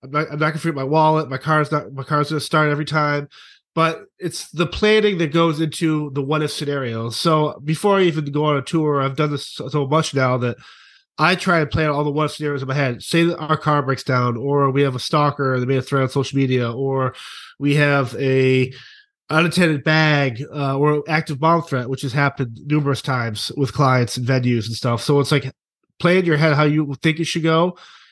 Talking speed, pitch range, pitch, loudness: 225 wpm, 135-160 Hz, 150 Hz, -19 LUFS